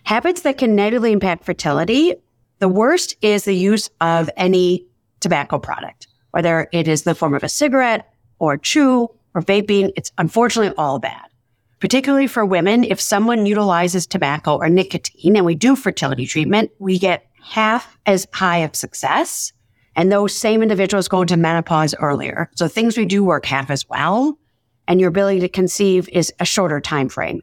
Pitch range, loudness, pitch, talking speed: 160-210 Hz, -17 LUFS, 185 Hz, 175 wpm